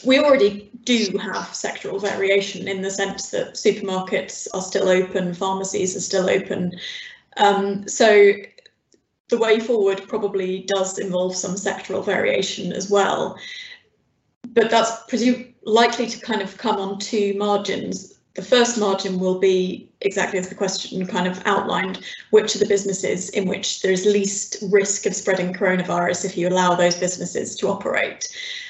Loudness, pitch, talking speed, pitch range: -21 LUFS, 200 Hz, 155 wpm, 190-215 Hz